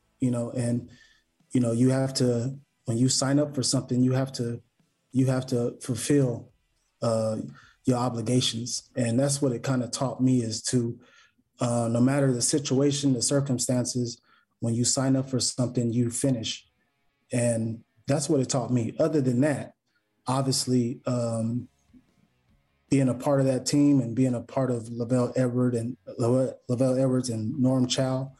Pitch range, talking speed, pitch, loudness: 120-130 Hz, 165 wpm, 125 Hz, -26 LUFS